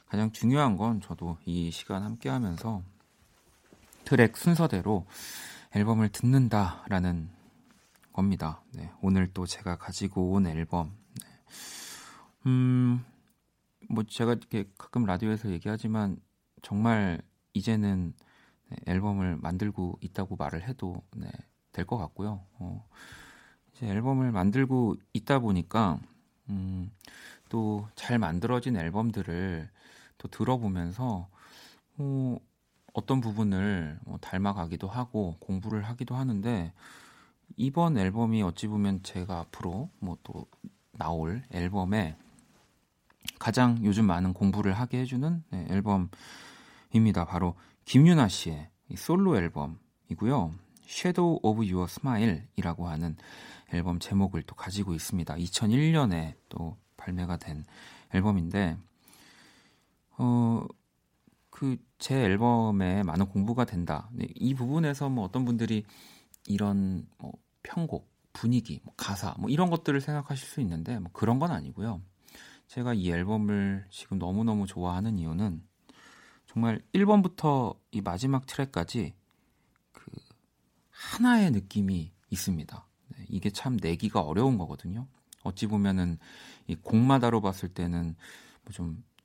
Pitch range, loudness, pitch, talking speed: 90-120 Hz, -30 LUFS, 100 Hz, 250 characters per minute